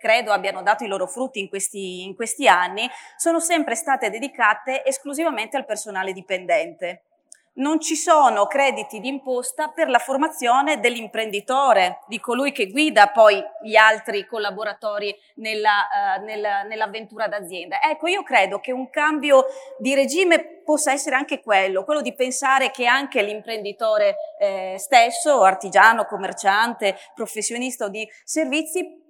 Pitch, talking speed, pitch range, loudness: 240 Hz, 135 wpm, 210-300 Hz, -20 LUFS